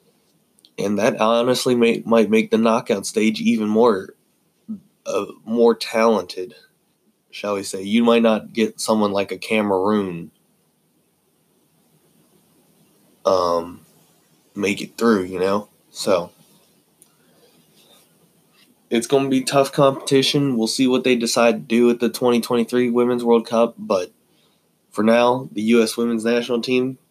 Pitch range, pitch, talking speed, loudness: 110-130 Hz, 115 Hz, 130 wpm, -19 LUFS